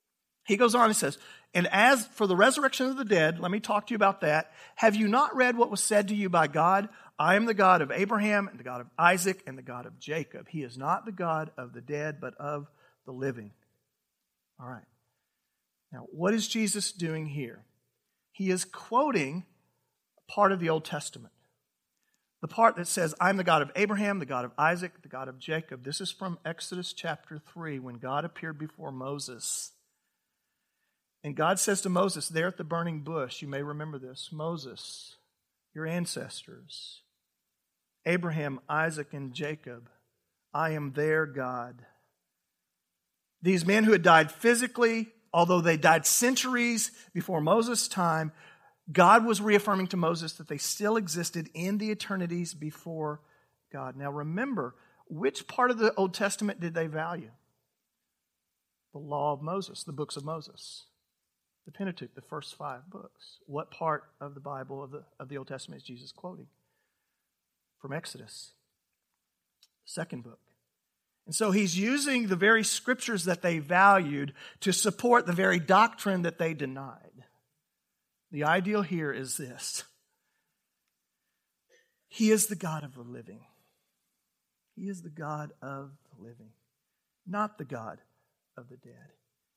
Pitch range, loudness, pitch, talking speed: 145-200 Hz, -28 LUFS, 165 Hz, 160 wpm